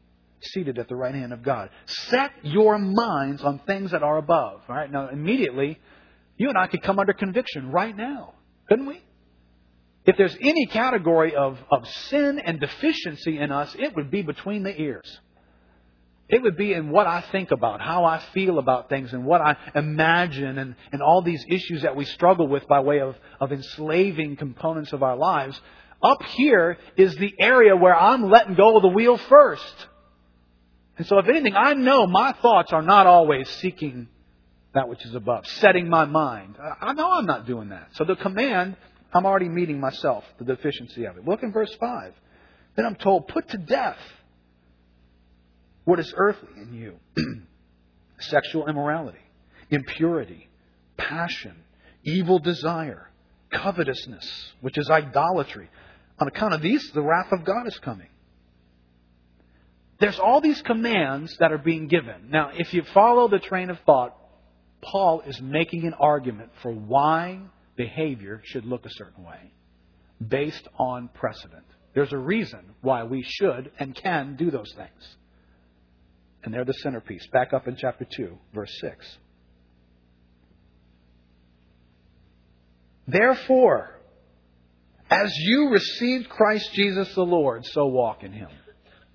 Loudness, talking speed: -22 LUFS, 155 wpm